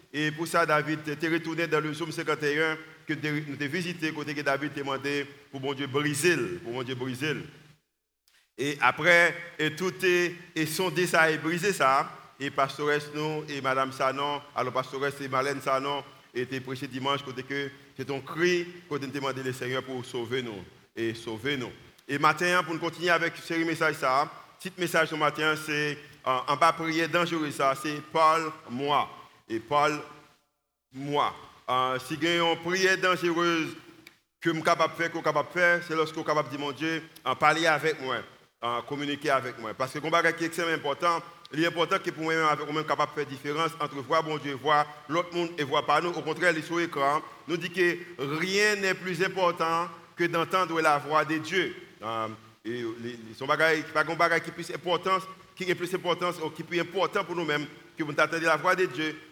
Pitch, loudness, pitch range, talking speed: 155 Hz, -28 LUFS, 140-170 Hz, 185 wpm